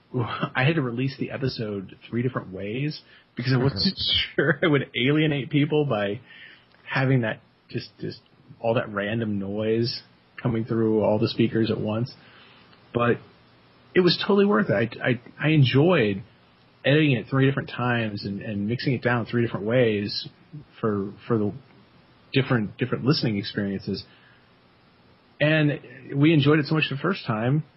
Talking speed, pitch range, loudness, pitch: 155 wpm, 105-140 Hz, -24 LUFS, 120 Hz